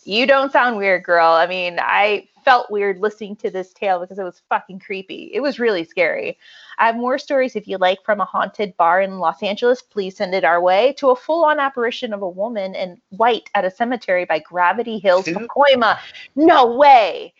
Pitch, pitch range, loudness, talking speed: 210 Hz, 185-260 Hz, -17 LUFS, 210 wpm